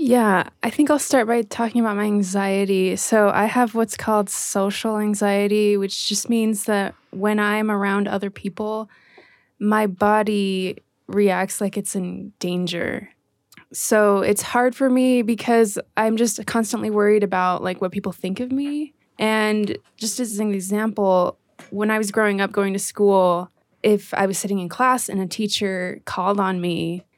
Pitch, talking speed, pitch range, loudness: 210 Hz, 165 wpm, 195-225 Hz, -21 LUFS